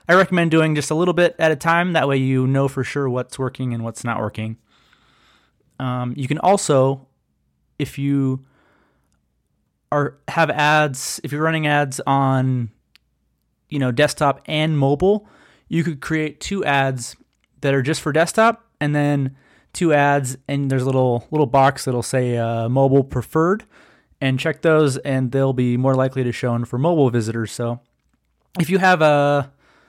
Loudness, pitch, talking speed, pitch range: -19 LUFS, 140 Hz, 170 wpm, 125-155 Hz